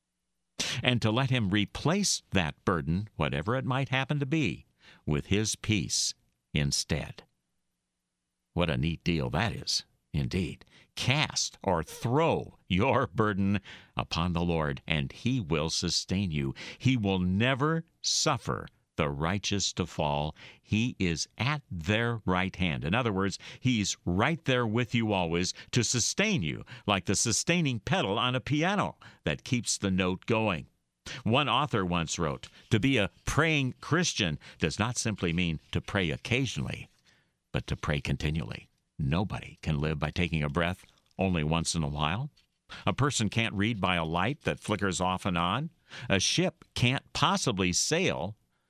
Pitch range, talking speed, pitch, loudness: 85-125 Hz, 155 wpm, 100 Hz, -29 LUFS